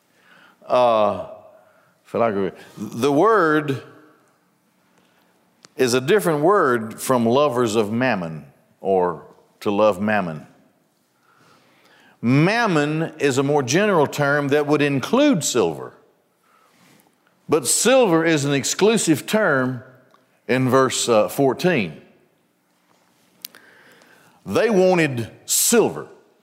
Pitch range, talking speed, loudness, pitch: 115-160 Hz, 85 wpm, -19 LUFS, 135 Hz